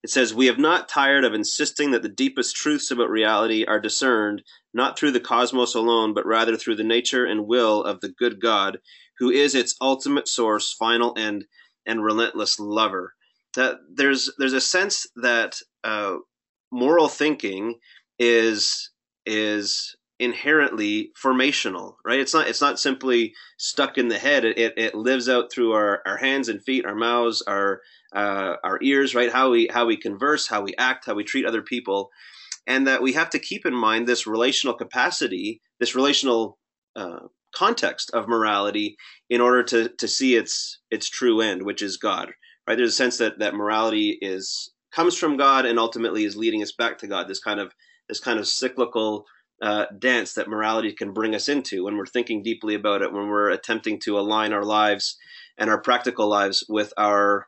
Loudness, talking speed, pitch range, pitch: -22 LUFS, 185 wpm, 105-135 Hz, 120 Hz